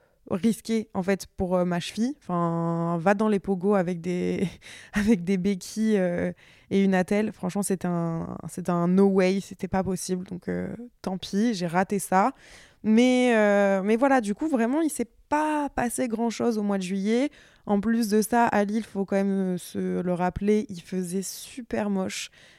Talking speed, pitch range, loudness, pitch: 190 wpm, 185-225 Hz, -26 LUFS, 195 Hz